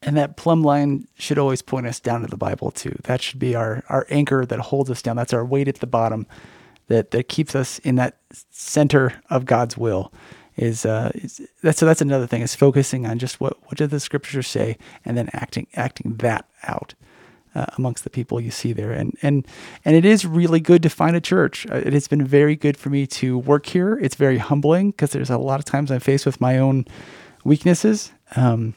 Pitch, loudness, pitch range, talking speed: 135 Hz, -20 LUFS, 120-145 Hz, 225 wpm